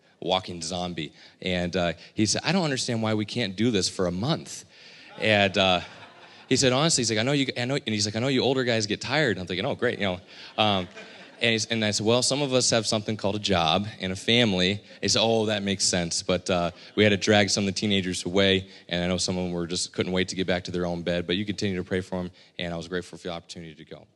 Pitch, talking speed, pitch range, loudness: 100 Hz, 285 wpm, 90-110 Hz, -25 LUFS